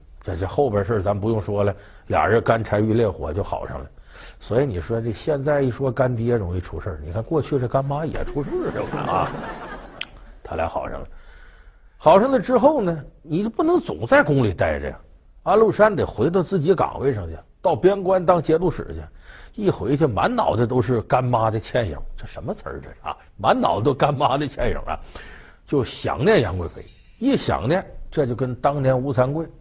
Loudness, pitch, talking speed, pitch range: -21 LUFS, 125 Hz, 280 characters per minute, 100-160 Hz